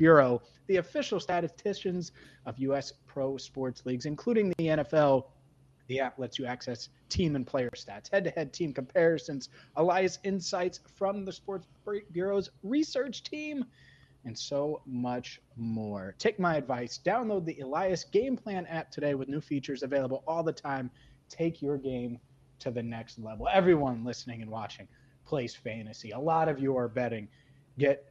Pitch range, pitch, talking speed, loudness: 125-175 Hz, 140 Hz, 160 wpm, -32 LUFS